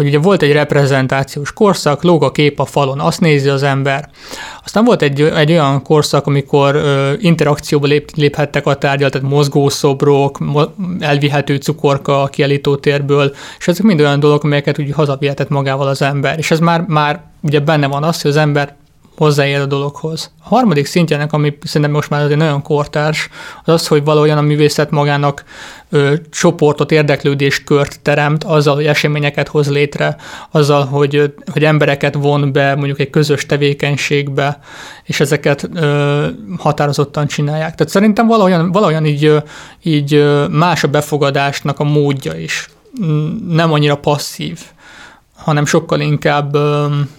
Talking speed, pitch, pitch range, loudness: 150 wpm, 145 Hz, 145-155 Hz, -13 LUFS